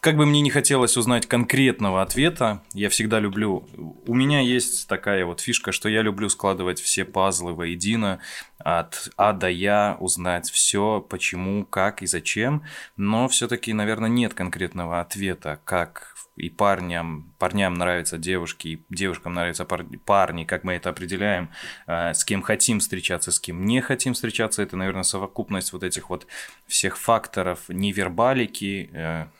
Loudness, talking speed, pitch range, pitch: -23 LUFS, 145 wpm, 90-110 Hz, 95 Hz